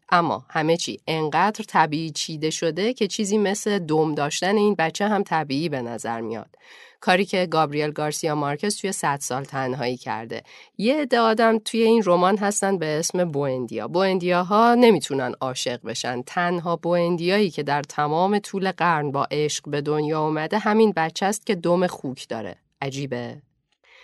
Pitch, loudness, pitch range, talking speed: 170 Hz, -22 LUFS, 145-205 Hz, 160 wpm